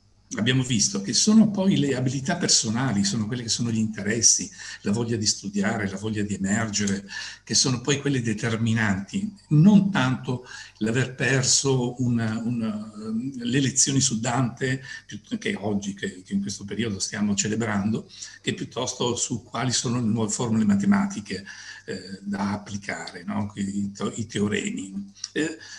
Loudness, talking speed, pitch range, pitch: -24 LUFS, 140 wpm, 105-140 Hz, 115 Hz